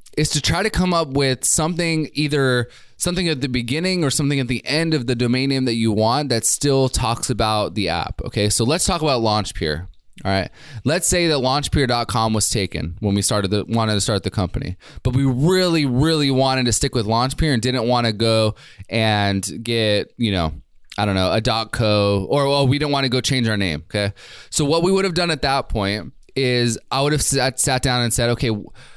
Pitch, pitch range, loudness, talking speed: 125 Hz, 110-145 Hz, -19 LUFS, 225 wpm